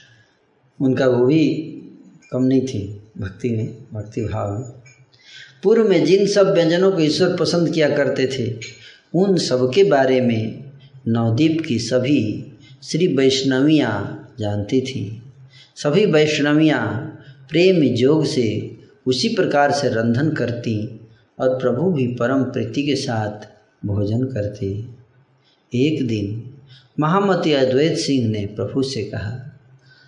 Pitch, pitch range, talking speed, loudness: 130 Hz, 115-145 Hz, 125 wpm, -19 LUFS